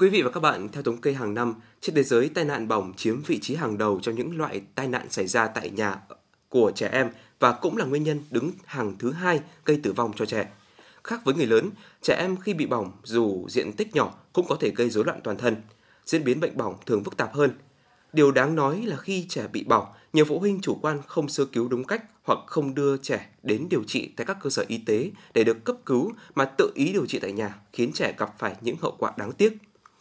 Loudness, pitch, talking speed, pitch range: -26 LUFS, 140 Hz, 255 wpm, 115-170 Hz